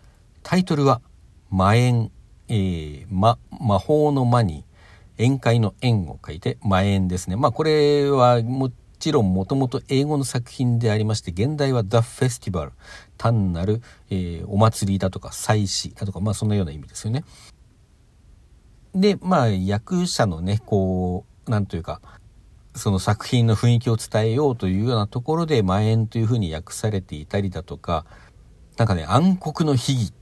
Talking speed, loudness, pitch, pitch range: 330 characters per minute, -22 LUFS, 110 Hz, 95-125 Hz